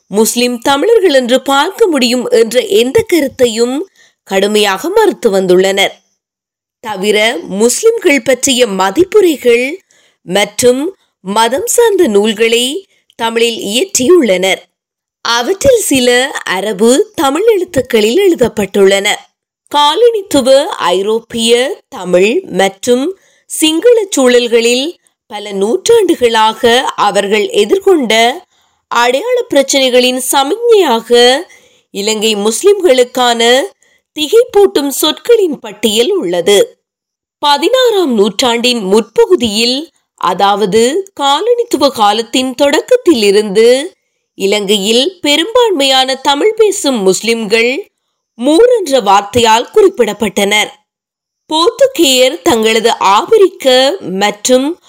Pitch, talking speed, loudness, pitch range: 260 Hz, 60 wpm, -10 LUFS, 225-375 Hz